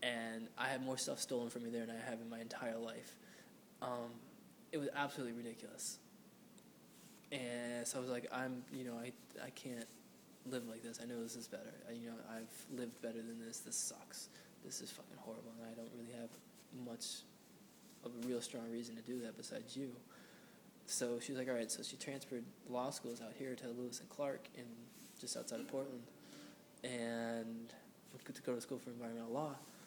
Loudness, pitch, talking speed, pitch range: -46 LUFS, 120 Hz, 205 wpm, 115-130 Hz